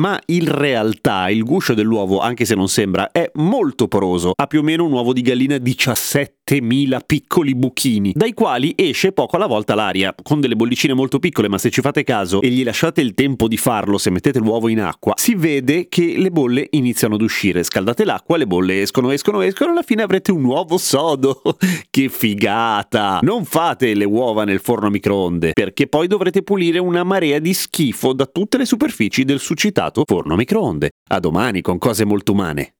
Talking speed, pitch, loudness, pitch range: 200 wpm, 130 Hz, -17 LUFS, 110-165 Hz